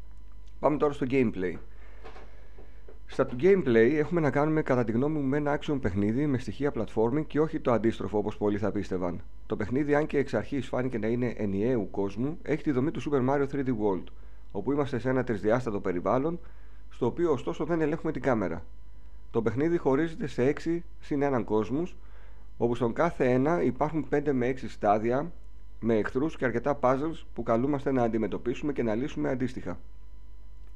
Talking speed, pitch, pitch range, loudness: 175 wpm, 120 Hz, 100-145 Hz, -29 LUFS